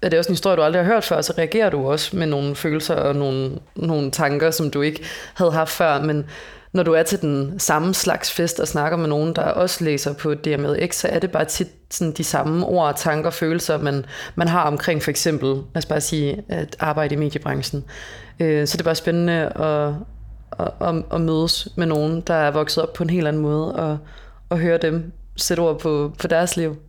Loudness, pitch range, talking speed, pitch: -21 LUFS, 150-170 Hz, 220 wpm, 160 Hz